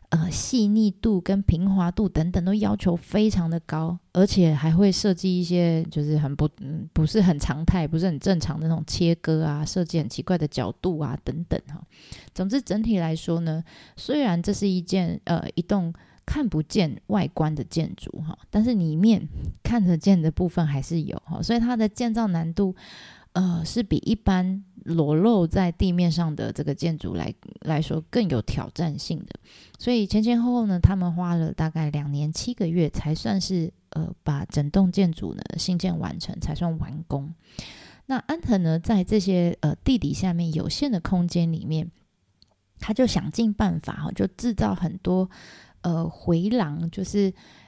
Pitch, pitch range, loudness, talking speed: 175 Hz, 160-195 Hz, -24 LUFS, 255 characters per minute